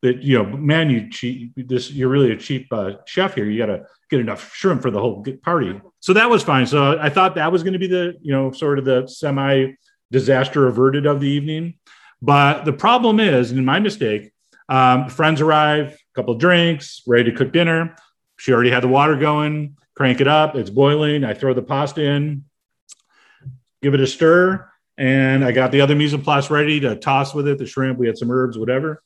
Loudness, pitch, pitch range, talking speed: -17 LUFS, 140 Hz, 130-155 Hz, 215 wpm